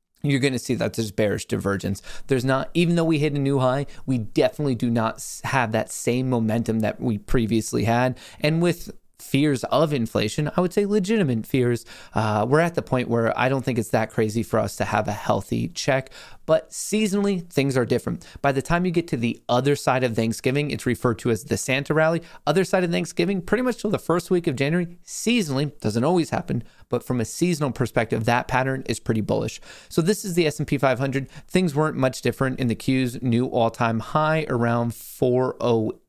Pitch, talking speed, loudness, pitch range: 130 Hz, 205 wpm, -23 LUFS, 115-155 Hz